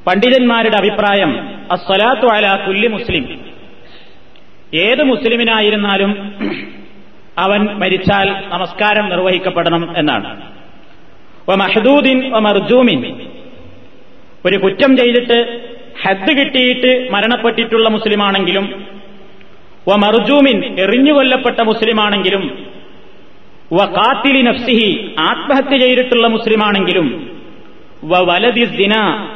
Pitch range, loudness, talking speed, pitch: 195-245 Hz, -12 LUFS, 55 wpm, 215 Hz